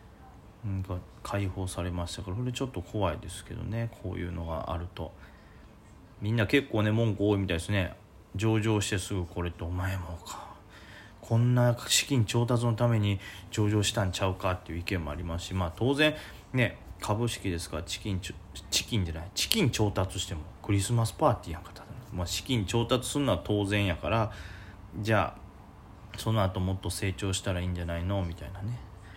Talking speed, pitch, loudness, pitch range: 370 characters per minute, 100 Hz, -30 LUFS, 90-110 Hz